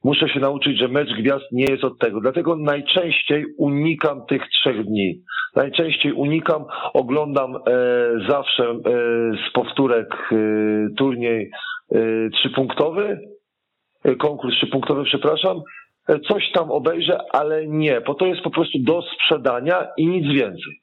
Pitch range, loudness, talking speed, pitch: 125-160 Hz, -20 LUFS, 120 wpm, 140 Hz